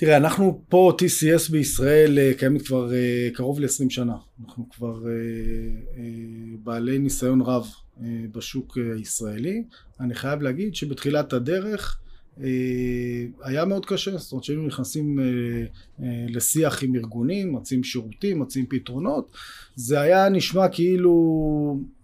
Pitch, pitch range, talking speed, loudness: 130 Hz, 120-150 Hz, 130 wpm, -23 LUFS